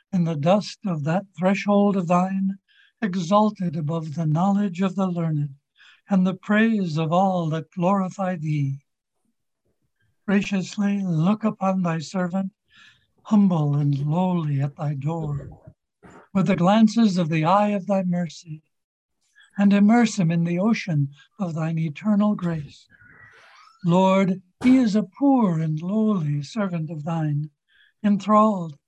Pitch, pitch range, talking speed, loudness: 185 Hz, 160-200 Hz, 135 wpm, -22 LUFS